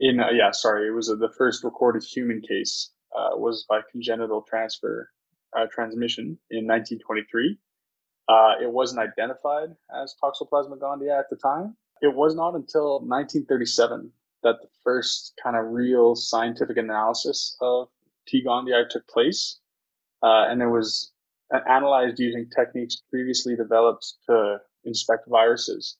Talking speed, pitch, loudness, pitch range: 140 wpm, 120 Hz, -24 LUFS, 115-135 Hz